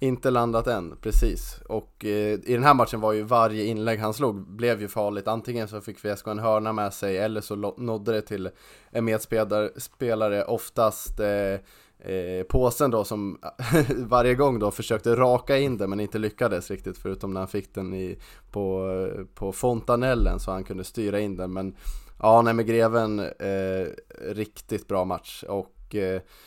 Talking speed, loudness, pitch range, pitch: 180 wpm, -26 LUFS, 100-115 Hz, 105 Hz